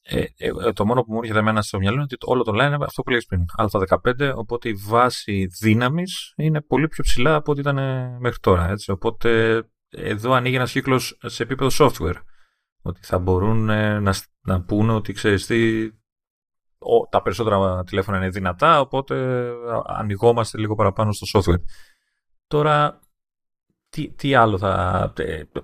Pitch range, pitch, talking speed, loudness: 100-130 Hz, 115 Hz, 155 wpm, -21 LUFS